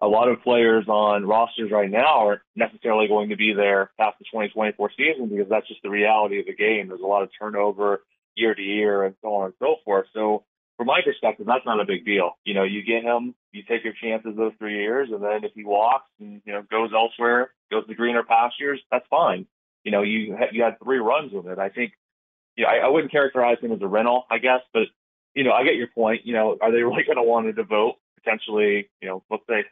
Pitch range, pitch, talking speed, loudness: 105-115 Hz, 110 Hz, 250 wpm, -22 LUFS